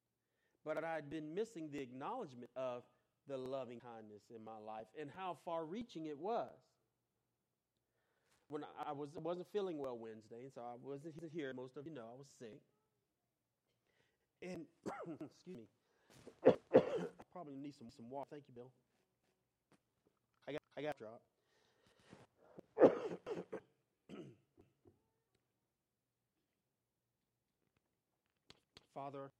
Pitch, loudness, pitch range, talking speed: 140 Hz, -43 LUFS, 125-160 Hz, 115 wpm